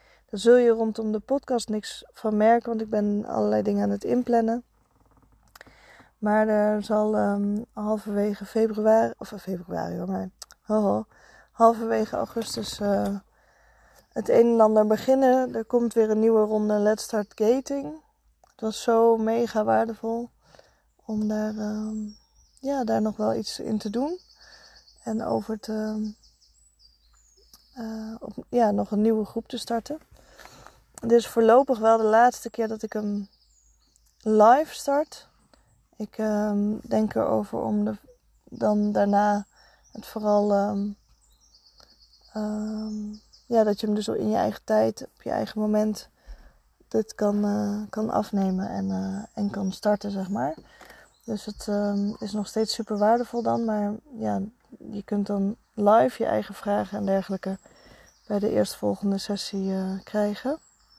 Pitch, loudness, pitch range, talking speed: 215 Hz, -25 LUFS, 200-225 Hz, 145 wpm